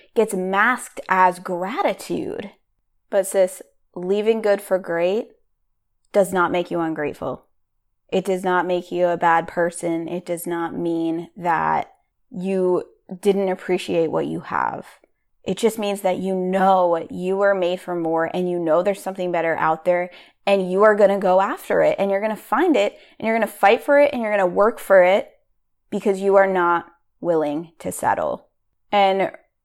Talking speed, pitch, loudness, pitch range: 180 wpm, 185 Hz, -20 LUFS, 175-200 Hz